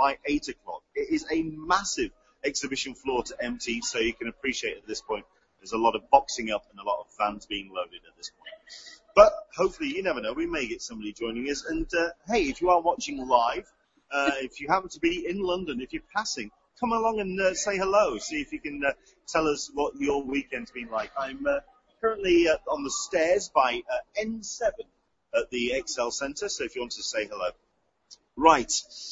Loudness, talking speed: -28 LUFS, 215 wpm